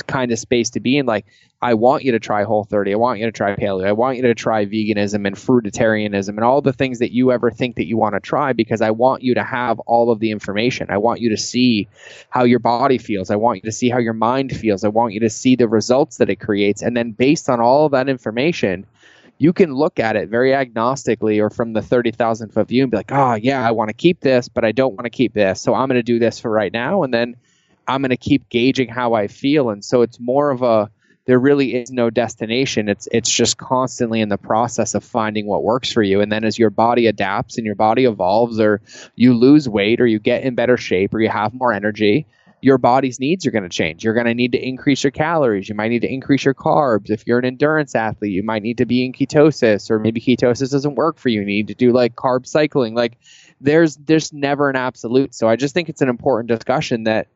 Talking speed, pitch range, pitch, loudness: 260 wpm, 110-130 Hz, 120 Hz, -17 LUFS